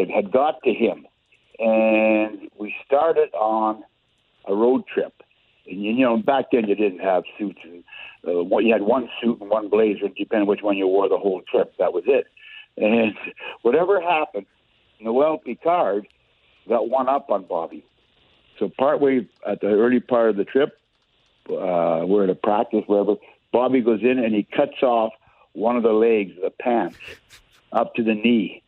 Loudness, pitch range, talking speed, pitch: -21 LUFS, 105-140 Hz, 175 wpm, 110 Hz